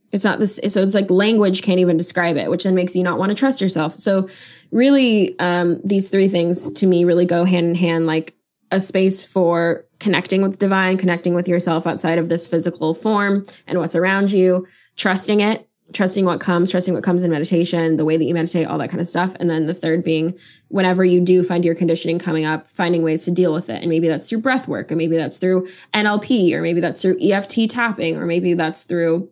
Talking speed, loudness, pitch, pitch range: 230 wpm, -18 LUFS, 175 Hz, 170-190 Hz